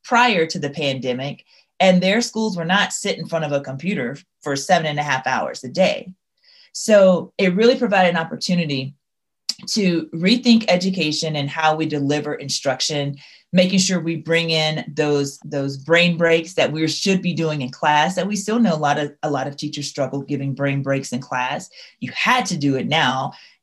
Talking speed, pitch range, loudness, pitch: 195 wpm, 145-185 Hz, -19 LUFS, 160 Hz